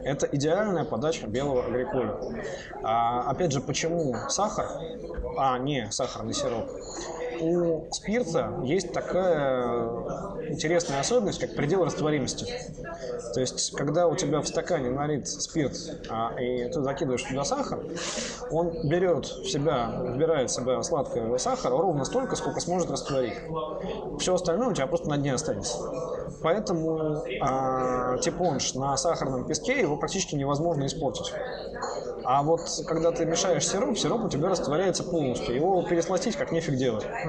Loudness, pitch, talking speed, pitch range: -28 LUFS, 160 Hz, 140 wpm, 135-170 Hz